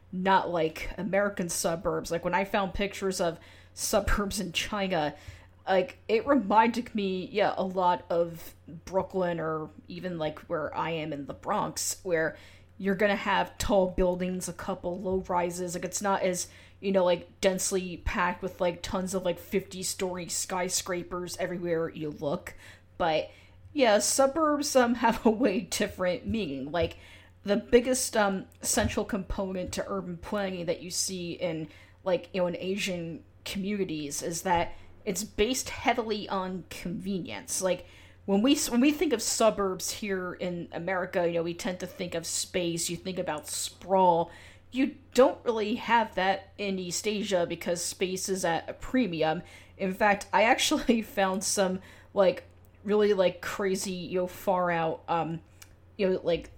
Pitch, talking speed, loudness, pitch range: 185 Hz, 160 wpm, -29 LUFS, 170-200 Hz